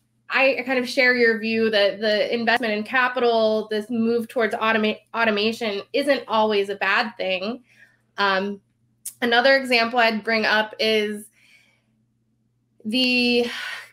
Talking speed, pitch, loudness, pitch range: 125 wpm, 220 Hz, -21 LUFS, 200-235 Hz